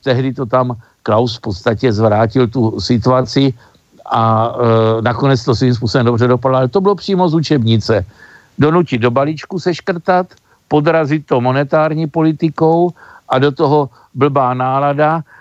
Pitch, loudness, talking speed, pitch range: 130 Hz, -14 LUFS, 145 wpm, 120-155 Hz